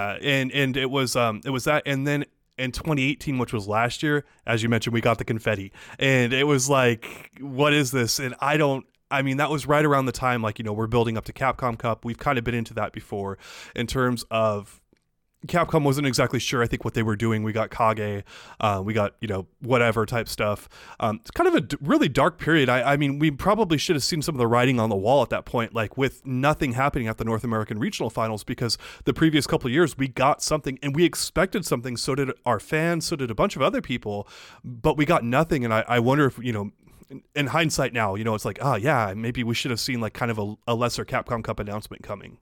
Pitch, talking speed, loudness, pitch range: 125 Hz, 255 wpm, -24 LUFS, 115-140 Hz